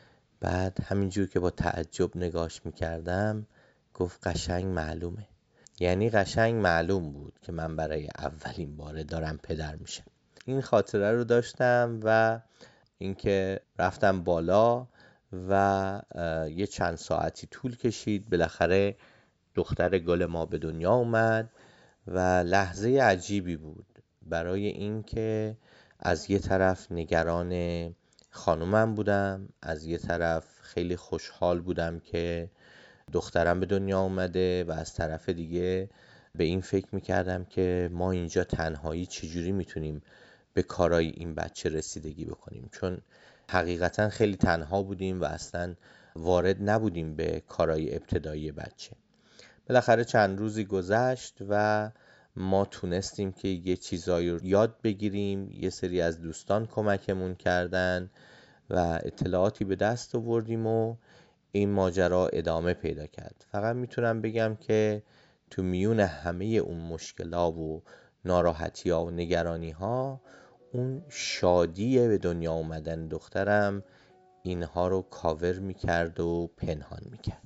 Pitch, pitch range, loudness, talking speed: 95 Hz, 85-105 Hz, -29 LUFS, 120 wpm